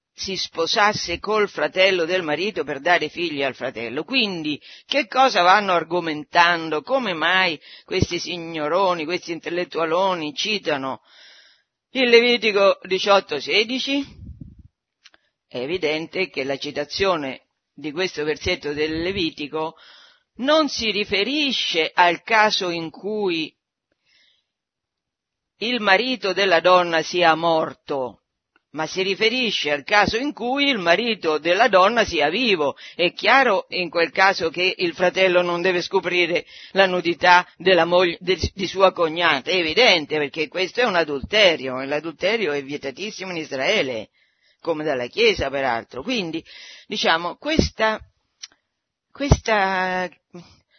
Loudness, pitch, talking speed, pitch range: -20 LUFS, 180 Hz, 120 wpm, 165-205 Hz